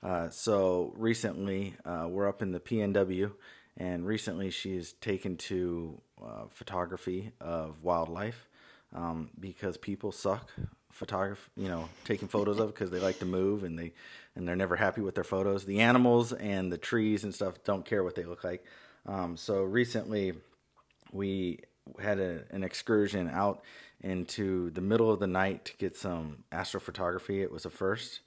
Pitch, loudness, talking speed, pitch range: 95 Hz, -33 LUFS, 165 wpm, 90-105 Hz